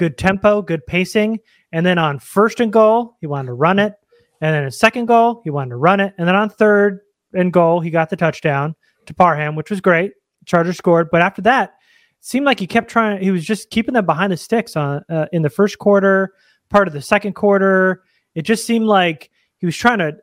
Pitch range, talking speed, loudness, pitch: 165-215 Hz, 230 wpm, -16 LUFS, 190 Hz